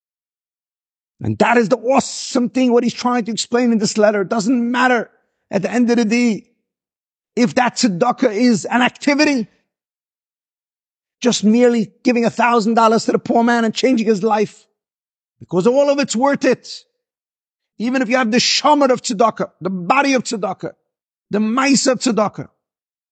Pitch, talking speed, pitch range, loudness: 240 Hz, 170 wpm, 220-255 Hz, -16 LUFS